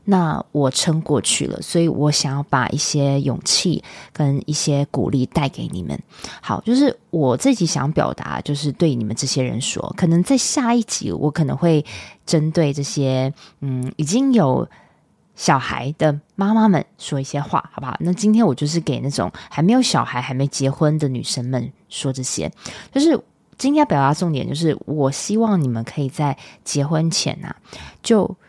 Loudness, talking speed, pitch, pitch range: -19 LUFS, 260 characters per minute, 150 Hz, 140-175 Hz